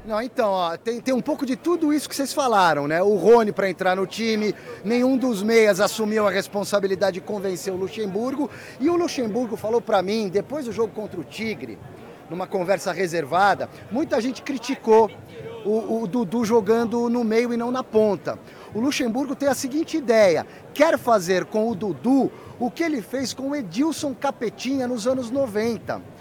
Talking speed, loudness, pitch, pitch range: 185 wpm, -22 LUFS, 230 Hz, 205-260 Hz